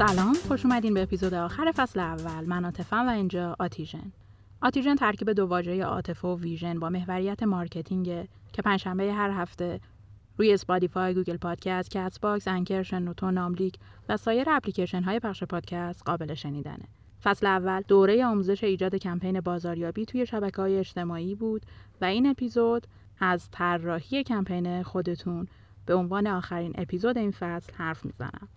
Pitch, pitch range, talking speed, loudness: 185 Hz, 175-200 Hz, 145 wpm, -28 LUFS